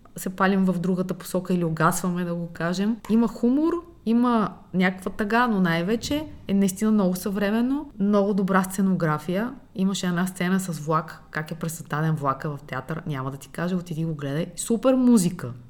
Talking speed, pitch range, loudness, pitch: 170 wpm, 165-210 Hz, -24 LUFS, 185 Hz